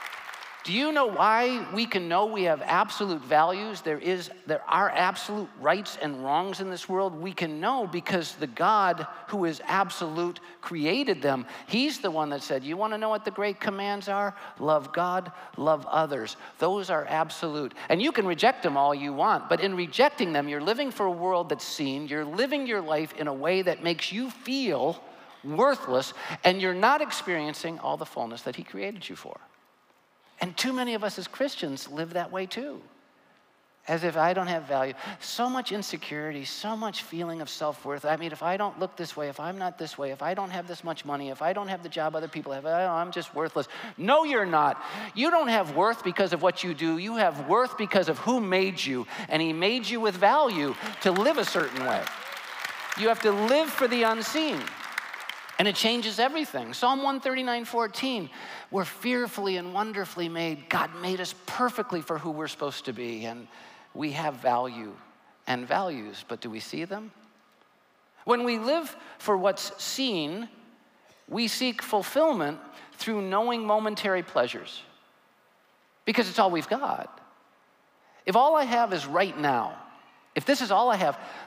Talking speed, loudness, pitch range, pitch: 190 wpm, -28 LUFS, 160-225 Hz, 185 Hz